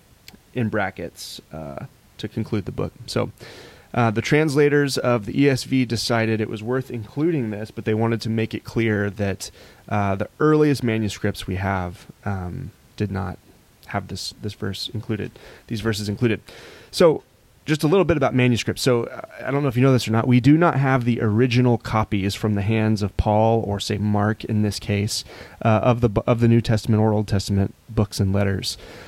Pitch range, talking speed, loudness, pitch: 105-125 Hz, 195 wpm, -22 LUFS, 110 Hz